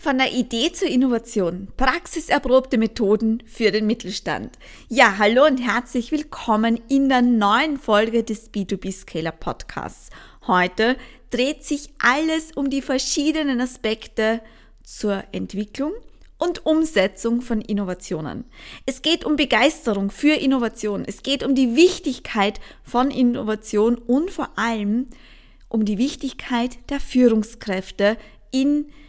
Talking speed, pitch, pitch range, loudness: 120 wpm, 245 Hz, 215-275 Hz, -20 LUFS